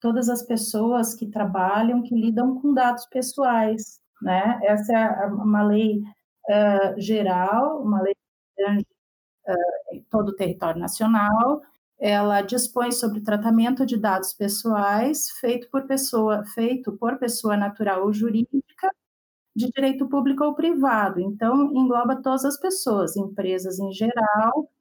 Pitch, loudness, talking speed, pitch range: 225 Hz, -23 LUFS, 135 wpm, 205-250 Hz